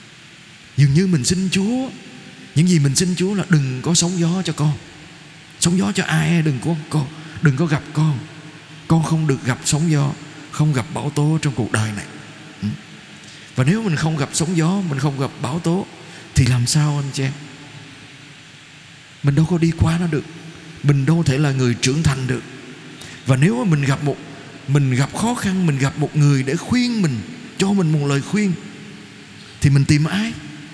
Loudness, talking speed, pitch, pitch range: -19 LUFS, 195 wpm, 155 Hz, 140-165 Hz